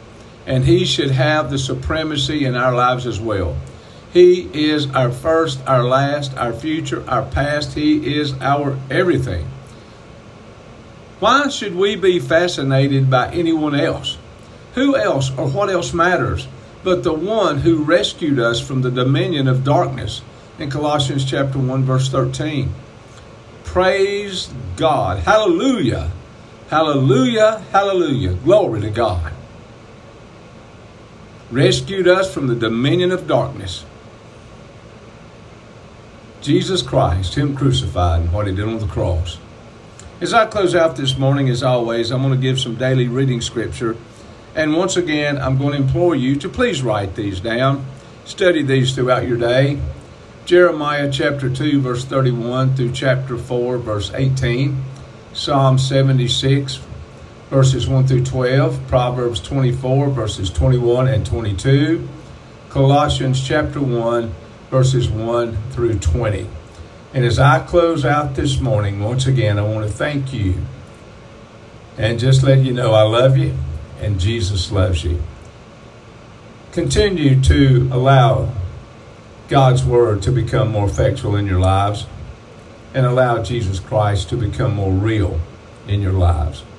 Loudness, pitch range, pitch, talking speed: -17 LUFS, 110-140 Hz, 130 Hz, 135 wpm